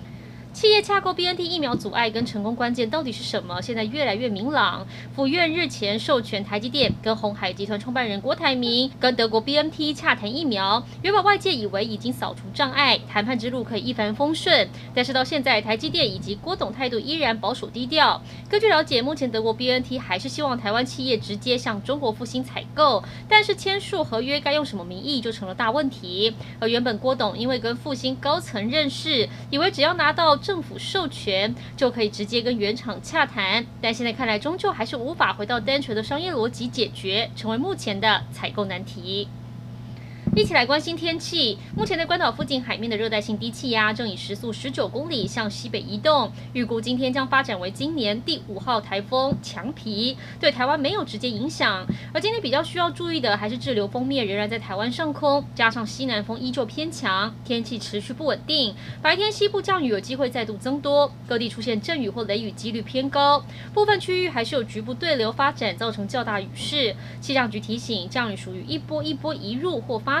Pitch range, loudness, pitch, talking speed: 215-295 Hz, -23 LUFS, 250 Hz, 320 characters per minute